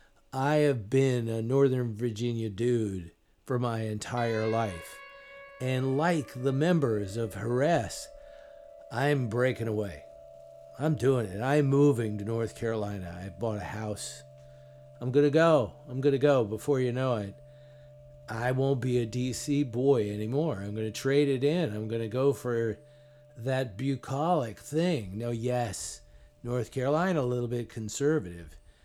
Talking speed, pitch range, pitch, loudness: 150 wpm, 105-140 Hz, 120 Hz, -29 LUFS